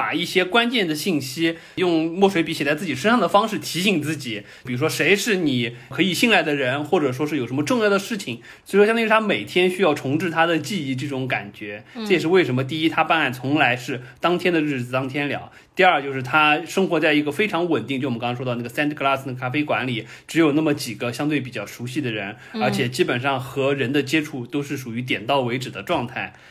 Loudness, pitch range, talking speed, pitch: -21 LUFS, 130-165 Hz, 370 characters per minute, 150 Hz